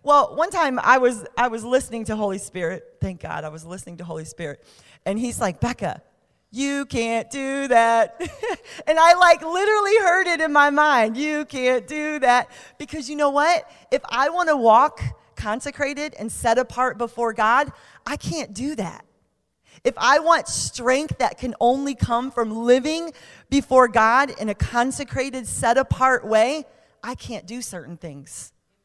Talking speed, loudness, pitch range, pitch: 170 wpm, -20 LUFS, 230-300 Hz, 255 Hz